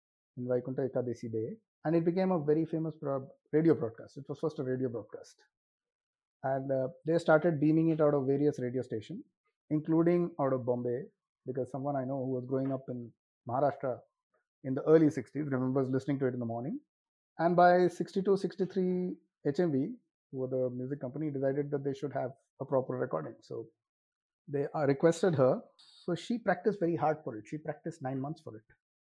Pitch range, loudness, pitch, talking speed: 130-170 Hz, -32 LUFS, 145 Hz, 180 wpm